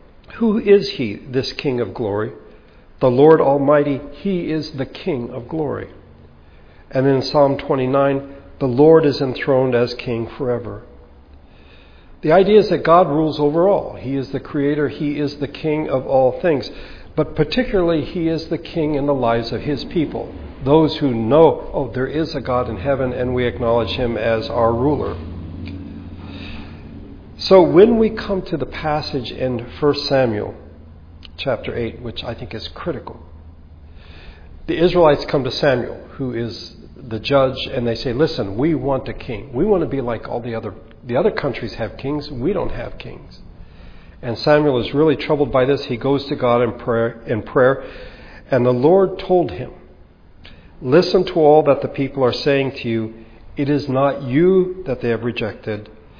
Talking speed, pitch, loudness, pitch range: 175 wpm, 130 Hz, -18 LUFS, 110-150 Hz